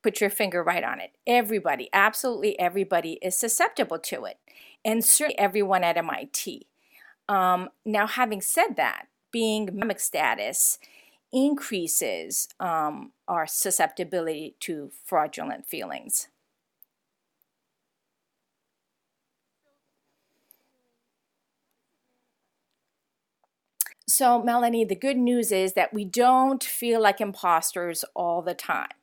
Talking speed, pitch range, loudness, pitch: 100 wpm, 185-240 Hz, -25 LUFS, 210 Hz